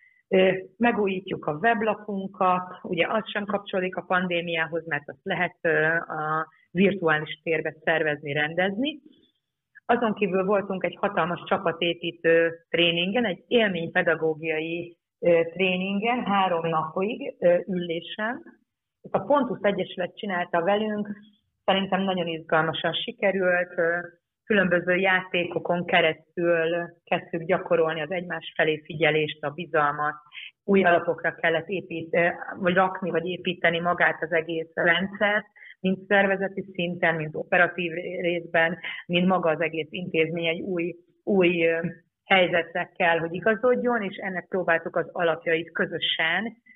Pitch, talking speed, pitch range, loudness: 175 Hz, 110 wpm, 165-195 Hz, -25 LUFS